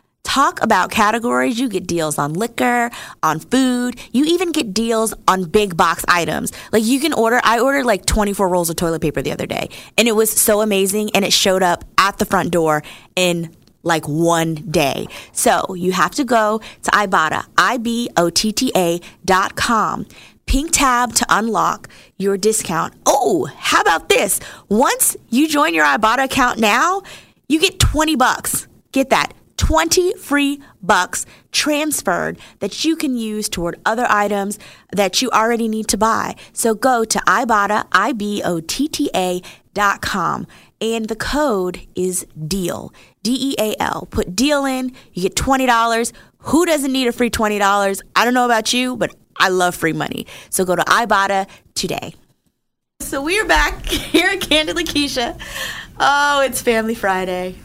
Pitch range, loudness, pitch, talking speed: 190-265 Hz, -17 LUFS, 220 Hz, 170 wpm